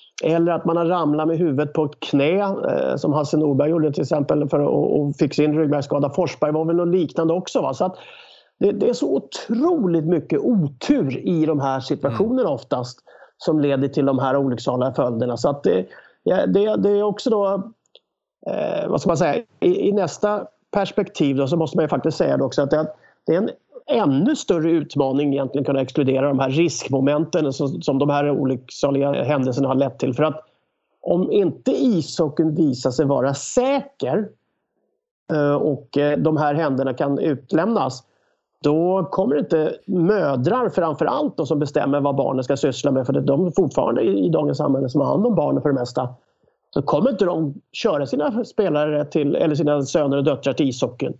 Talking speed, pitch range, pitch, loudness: 185 wpm, 140-170 Hz, 150 Hz, -20 LUFS